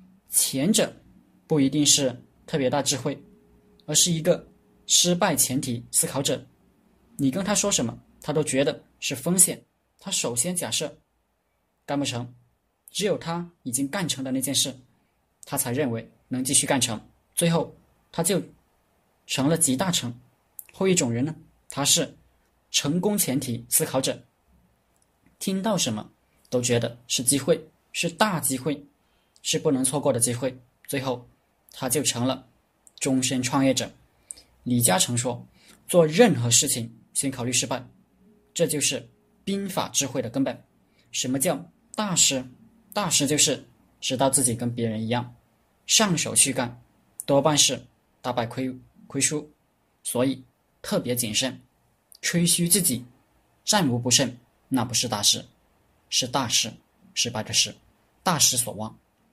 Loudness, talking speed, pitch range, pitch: -23 LUFS, 205 characters per minute, 125-165 Hz, 135 Hz